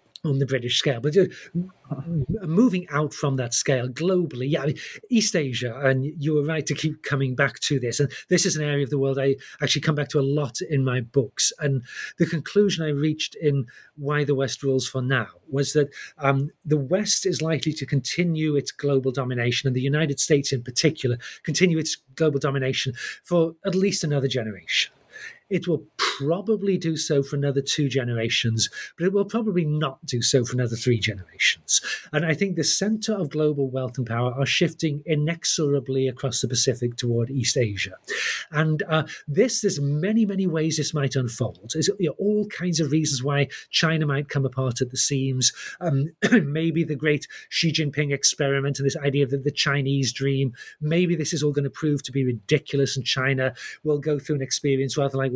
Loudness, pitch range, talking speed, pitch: -24 LUFS, 135-160 Hz, 195 wpm, 145 Hz